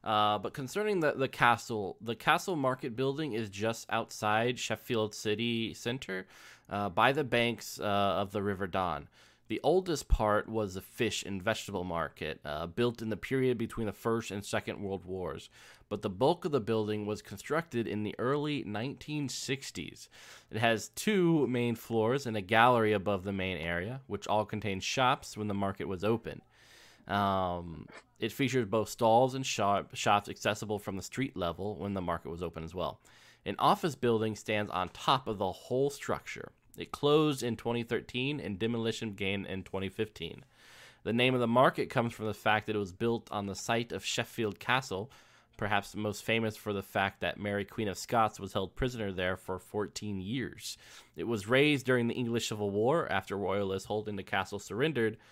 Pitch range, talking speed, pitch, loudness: 100-120 Hz, 185 wpm, 110 Hz, -32 LUFS